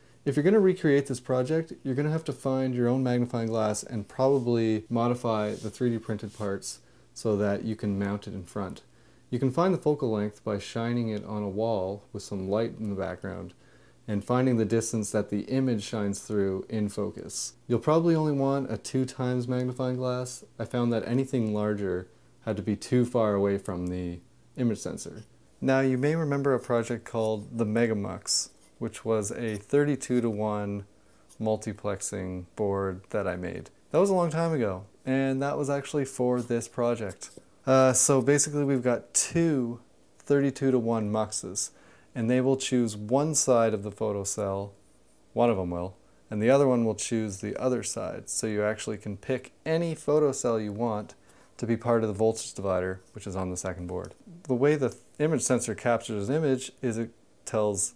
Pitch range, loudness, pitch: 105-130 Hz, -28 LUFS, 115 Hz